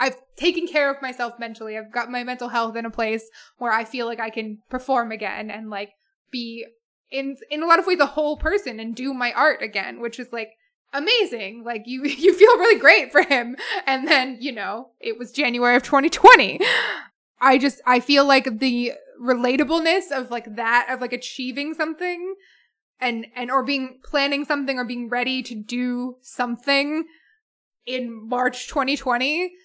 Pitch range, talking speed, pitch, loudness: 240-285 Hz, 180 wpm, 255 Hz, -20 LUFS